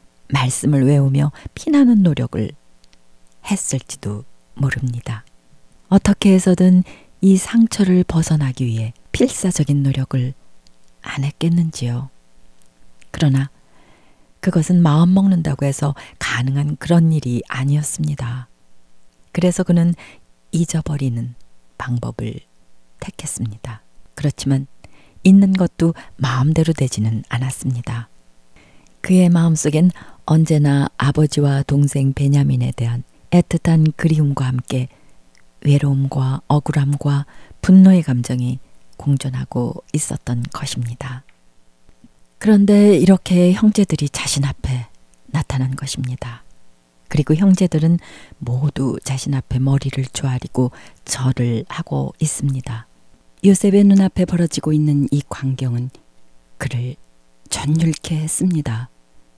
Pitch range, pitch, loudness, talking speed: 120-160 Hz, 135 Hz, -17 LUFS, 245 characters per minute